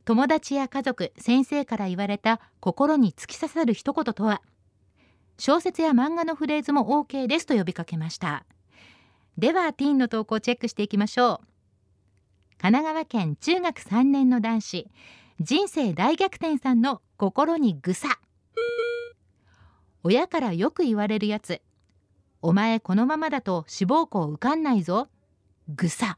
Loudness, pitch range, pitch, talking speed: -25 LUFS, 175-285 Hz, 230 Hz, 275 characters per minute